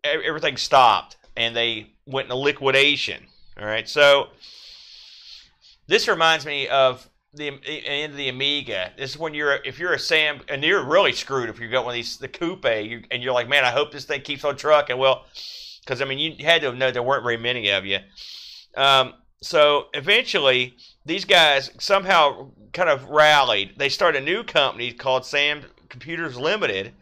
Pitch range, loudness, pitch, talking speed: 125-145 Hz, -20 LUFS, 135 Hz, 180 wpm